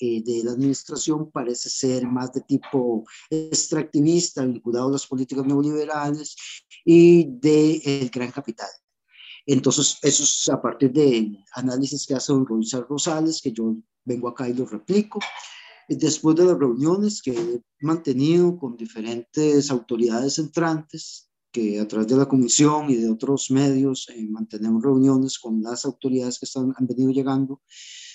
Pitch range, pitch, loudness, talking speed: 125-150 Hz, 135 Hz, -22 LUFS, 145 wpm